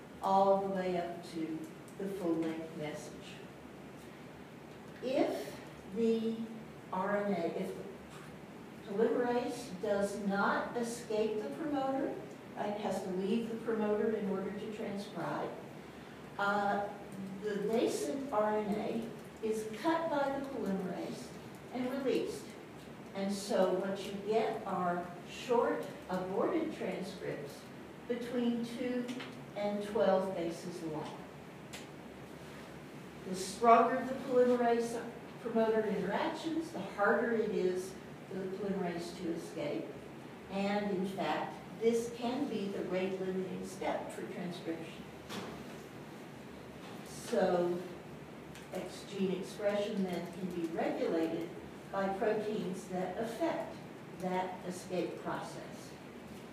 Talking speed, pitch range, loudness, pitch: 100 wpm, 190-230 Hz, -36 LUFS, 205 Hz